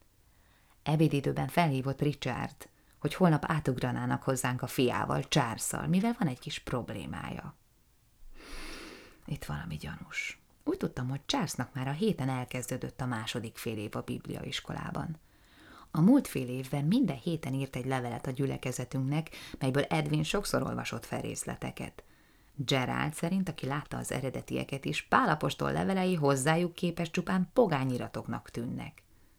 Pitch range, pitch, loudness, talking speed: 125-160 Hz, 135 Hz, -32 LUFS, 130 wpm